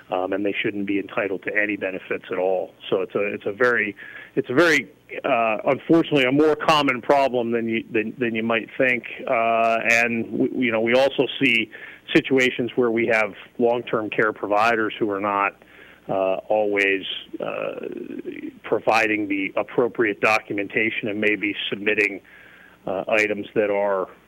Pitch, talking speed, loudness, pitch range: 115 Hz, 160 wpm, -21 LUFS, 100-135 Hz